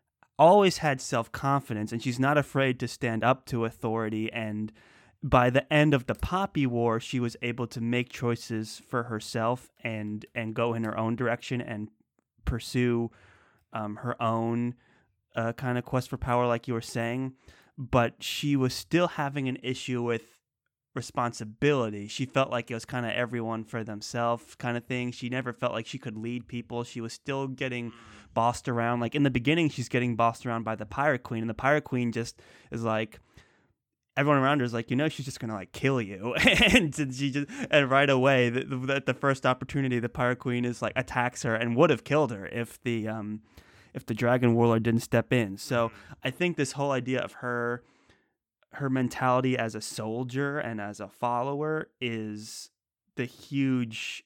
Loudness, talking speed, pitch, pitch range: -28 LUFS, 190 wpm, 120 Hz, 115-130 Hz